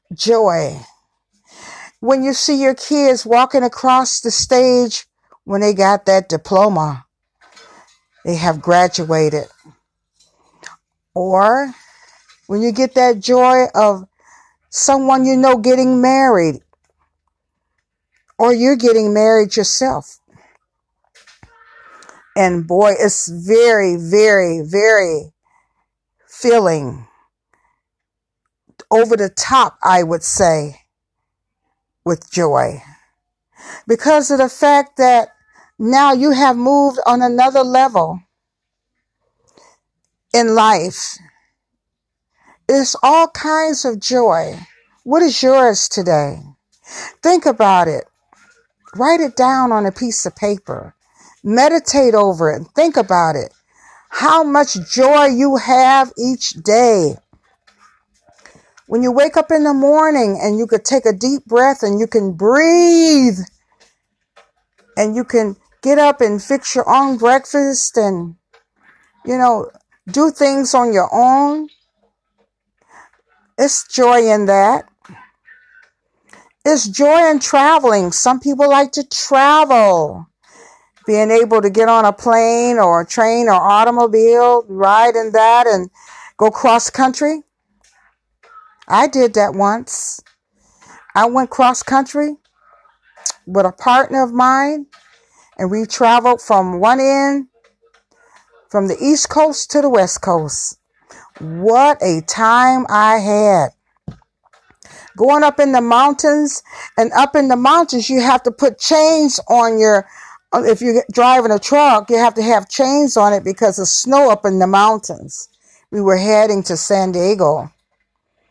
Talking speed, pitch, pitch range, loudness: 120 wpm, 245 Hz, 210-280 Hz, -13 LUFS